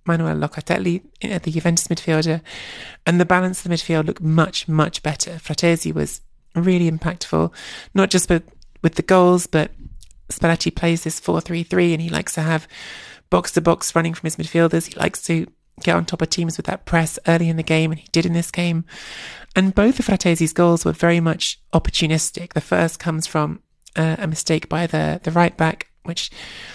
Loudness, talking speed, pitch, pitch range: -20 LUFS, 195 wpm, 165 Hz, 160-175 Hz